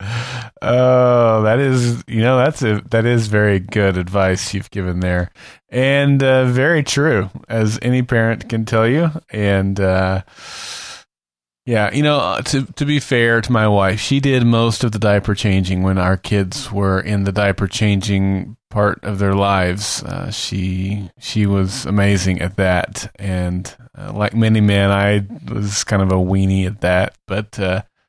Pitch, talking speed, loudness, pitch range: 105 Hz, 170 wpm, -17 LUFS, 95-120 Hz